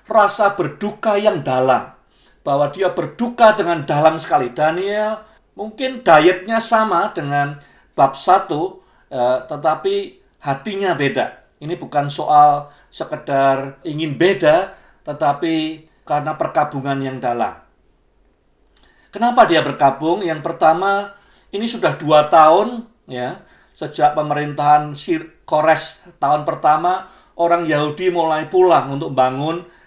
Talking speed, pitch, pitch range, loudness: 105 wpm, 160 Hz, 150-200 Hz, -17 LUFS